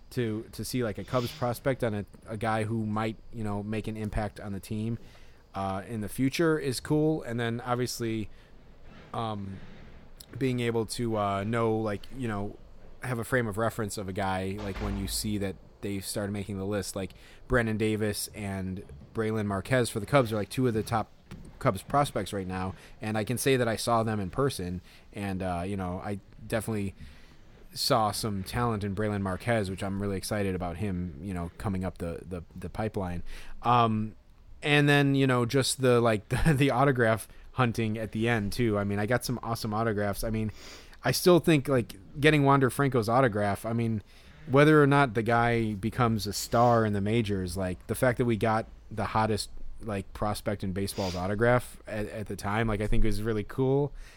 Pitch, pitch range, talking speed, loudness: 110 Hz, 100-120 Hz, 200 wpm, -29 LUFS